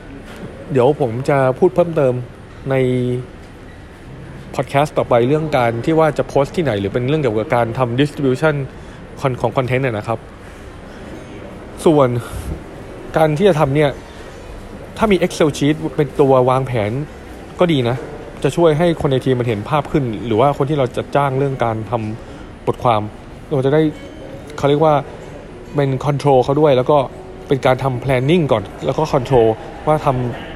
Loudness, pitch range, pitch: -17 LUFS, 120-150 Hz, 130 Hz